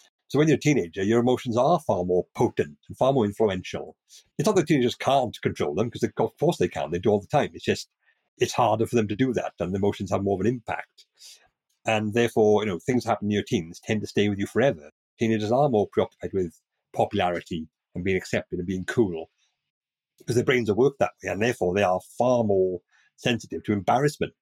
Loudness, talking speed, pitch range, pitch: -25 LUFS, 230 wpm, 90-115 Hz, 105 Hz